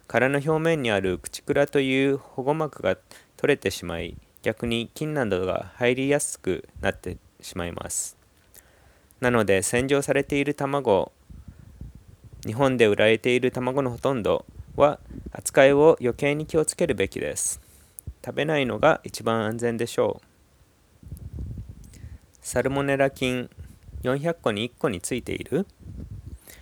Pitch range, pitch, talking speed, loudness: 100-140 Hz, 120 Hz, 255 characters per minute, -24 LUFS